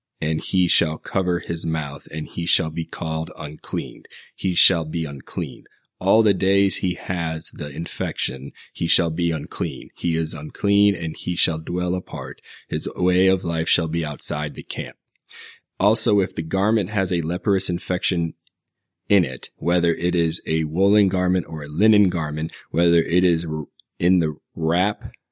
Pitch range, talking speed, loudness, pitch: 80-95 Hz, 165 wpm, -22 LUFS, 85 Hz